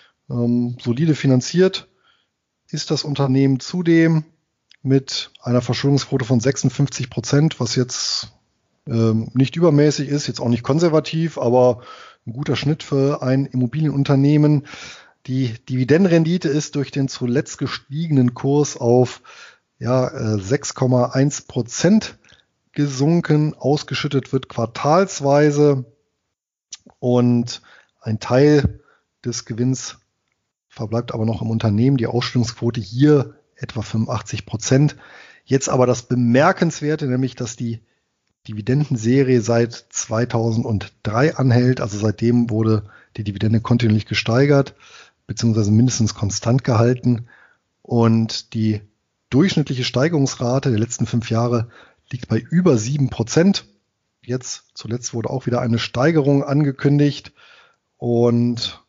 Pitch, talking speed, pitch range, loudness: 125 Hz, 105 wpm, 115-145 Hz, -19 LUFS